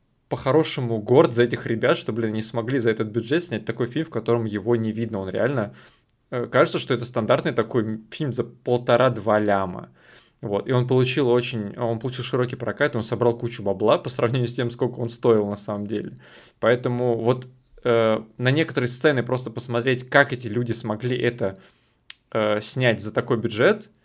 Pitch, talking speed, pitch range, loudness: 120 Hz, 180 wpm, 110-125 Hz, -23 LUFS